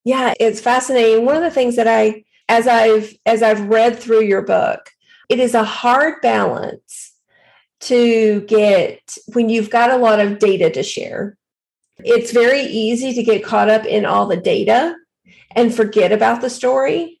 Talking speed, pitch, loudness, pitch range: 170 wpm, 235 Hz, -15 LUFS, 220-265 Hz